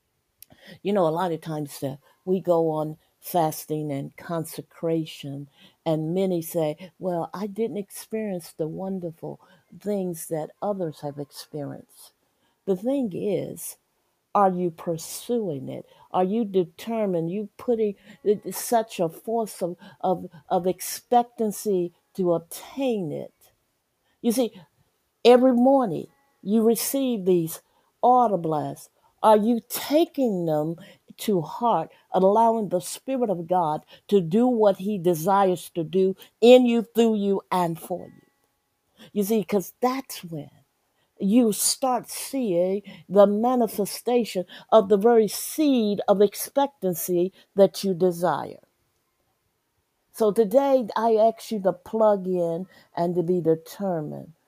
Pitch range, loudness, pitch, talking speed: 170-225 Hz, -24 LUFS, 190 Hz, 125 wpm